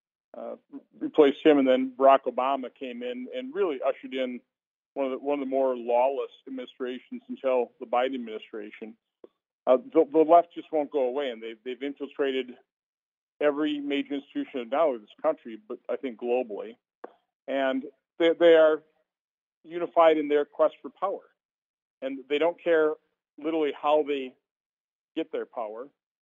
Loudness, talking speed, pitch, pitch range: -26 LUFS, 160 wpm, 145 Hz, 130-160 Hz